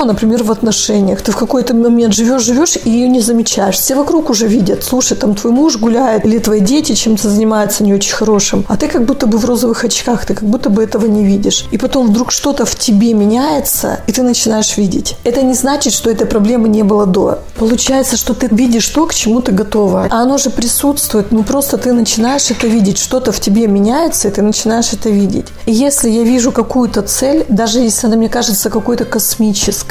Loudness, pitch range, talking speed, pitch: -11 LUFS, 215-250 Hz, 210 wpm, 230 Hz